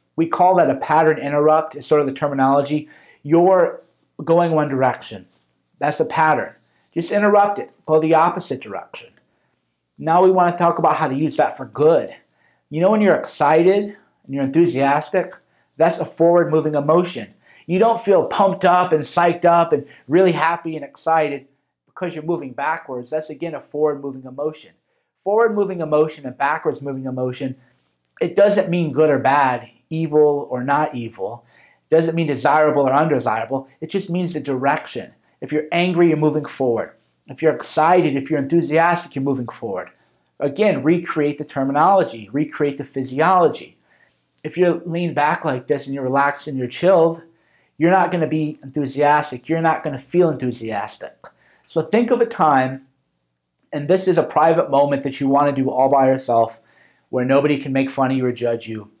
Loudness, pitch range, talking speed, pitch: -18 LUFS, 135-170 Hz, 180 wpm, 155 Hz